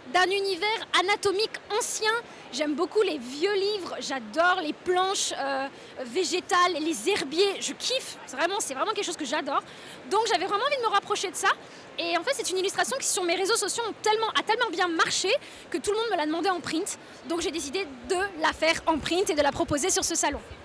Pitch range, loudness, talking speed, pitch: 330-410 Hz, -26 LUFS, 225 wpm, 370 Hz